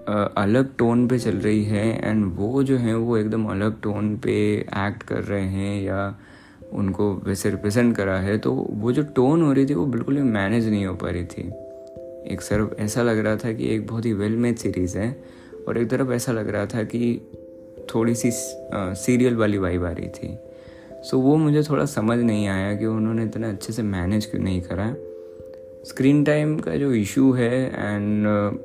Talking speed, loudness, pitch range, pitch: 200 wpm, -22 LUFS, 100-125 Hz, 110 Hz